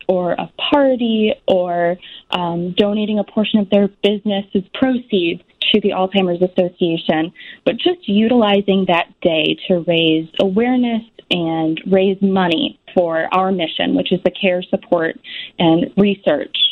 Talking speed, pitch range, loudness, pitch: 135 wpm, 175-215 Hz, -17 LUFS, 195 Hz